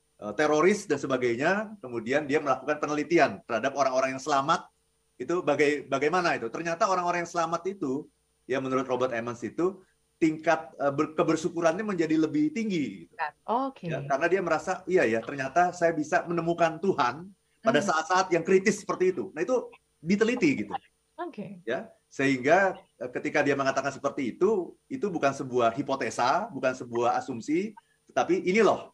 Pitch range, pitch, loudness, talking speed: 140-190 Hz, 165 Hz, -27 LUFS, 140 wpm